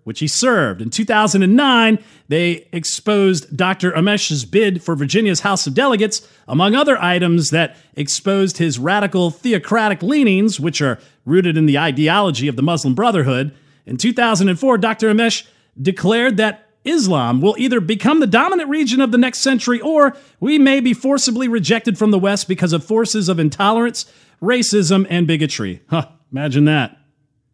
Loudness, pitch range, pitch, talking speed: -16 LUFS, 155-230 Hz, 195 Hz, 155 wpm